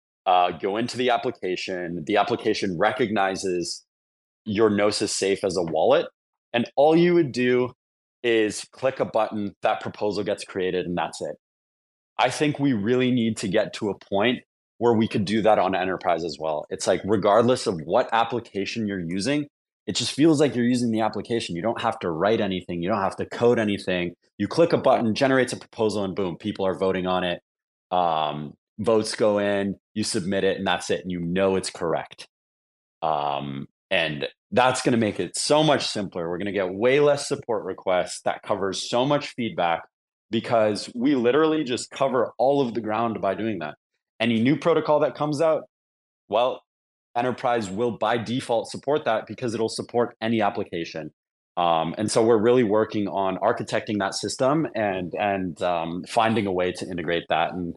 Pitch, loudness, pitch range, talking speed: 110 Hz, -24 LUFS, 95-120 Hz, 185 wpm